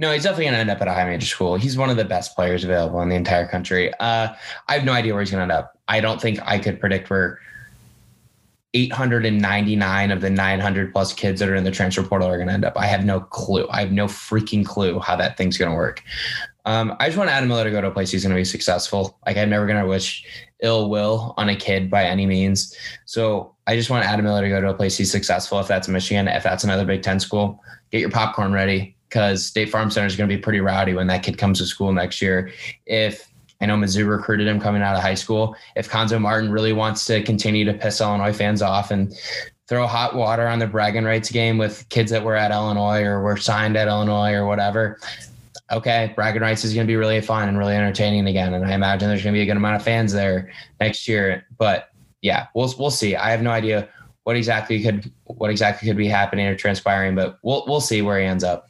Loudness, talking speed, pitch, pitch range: -20 LUFS, 250 wpm, 105 Hz, 95-110 Hz